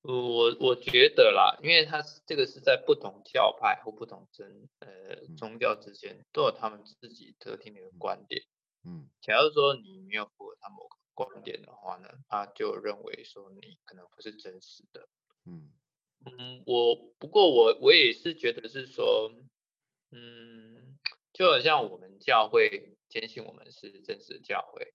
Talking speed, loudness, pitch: 240 characters per minute, -26 LUFS, 400 Hz